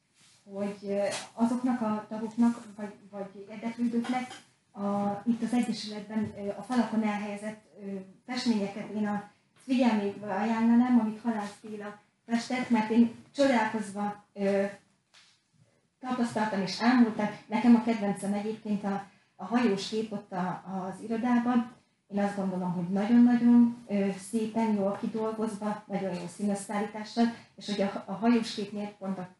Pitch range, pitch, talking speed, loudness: 200-230 Hz, 210 Hz, 120 wpm, -29 LUFS